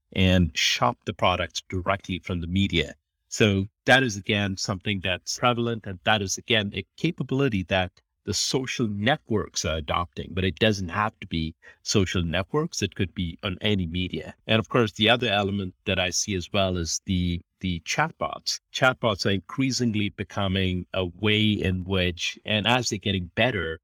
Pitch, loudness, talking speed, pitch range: 100 Hz, -25 LUFS, 175 wpm, 90-110 Hz